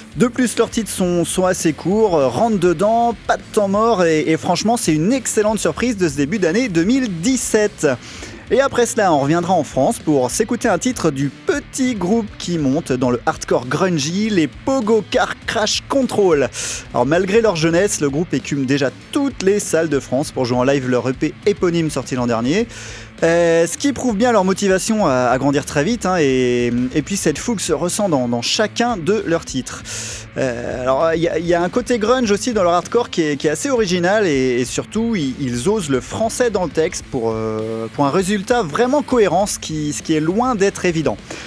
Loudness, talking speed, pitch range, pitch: -17 LUFS, 205 wpm, 140-225 Hz, 175 Hz